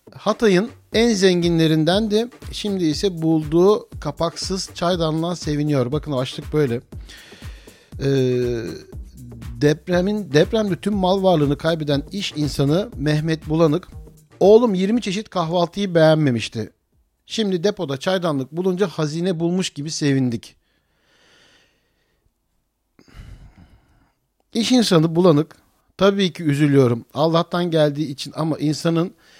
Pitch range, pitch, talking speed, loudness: 145-190 Hz, 165 Hz, 100 wpm, -19 LUFS